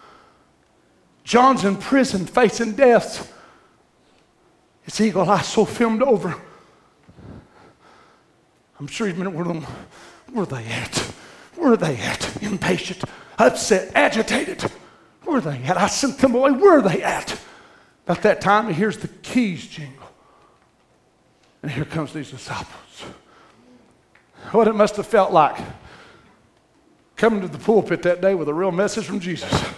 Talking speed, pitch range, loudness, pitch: 140 wpm, 170-230 Hz, -20 LUFS, 200 Hz